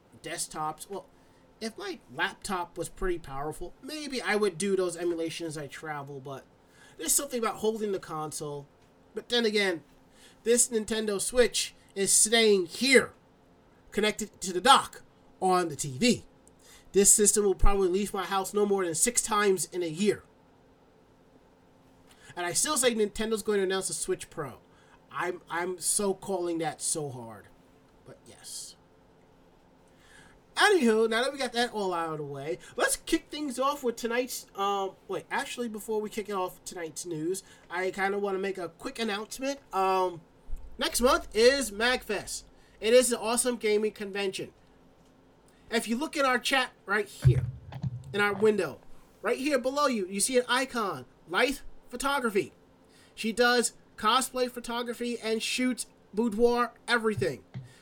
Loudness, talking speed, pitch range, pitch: -28 LUFS, 155 wpm, 155-235 Hz, 195 Hz